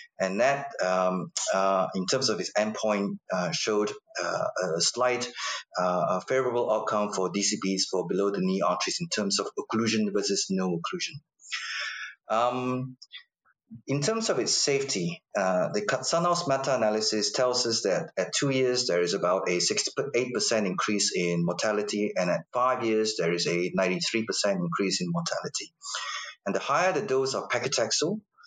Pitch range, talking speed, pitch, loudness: 100-135 Hz, 155 wpm, 110 Hz, -27 LUFS